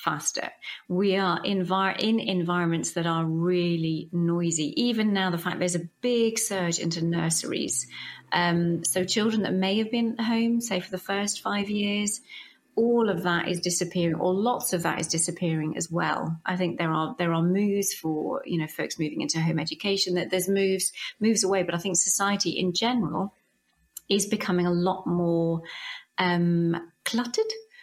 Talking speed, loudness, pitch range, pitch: 175 wpm, -26 LUFS, 170-200 Hz, 180 Hz